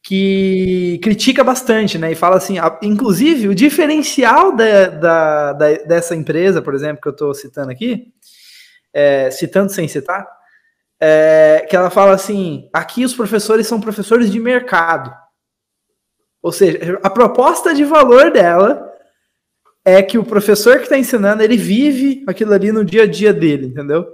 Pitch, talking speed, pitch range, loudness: 200 Hz, 155 wpm, 165-240 Hz, -12 LUFS